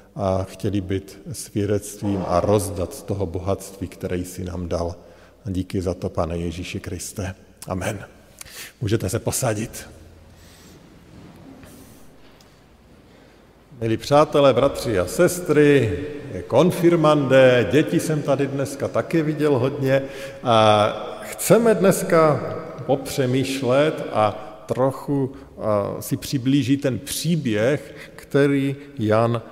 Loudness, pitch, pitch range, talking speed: -21 LUFS, 115 Hz, 95-140 Hz, 105 wpm